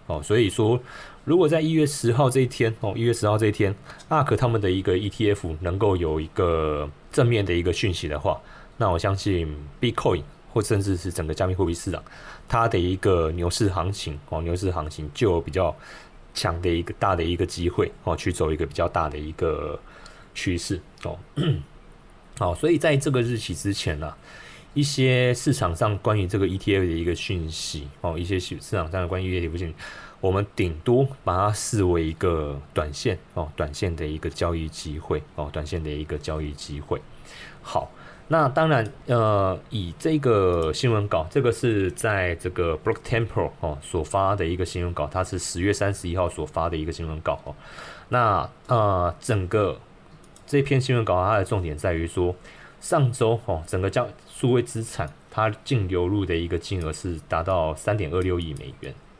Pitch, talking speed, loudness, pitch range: 95 Hz, 285 characters per minute, -25 LUFS, 85-110 Hz